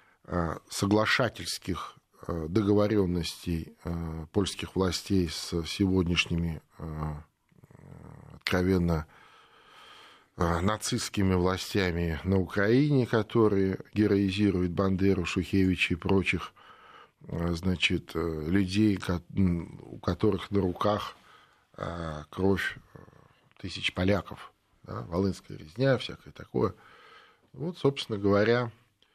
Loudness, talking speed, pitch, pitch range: -29 LUFS, 70 wpm, 95 Hz, 85-105 Hz